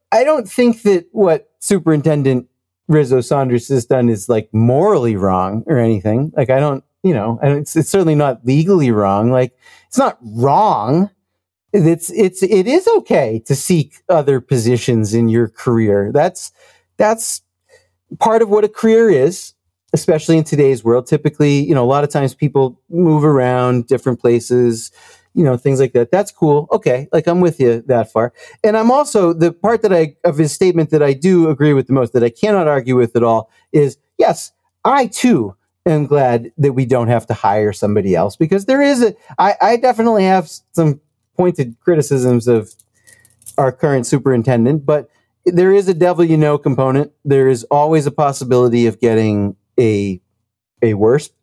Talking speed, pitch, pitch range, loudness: 180 wpm, 140 Hz, 120-170 Hz, -14 LUFS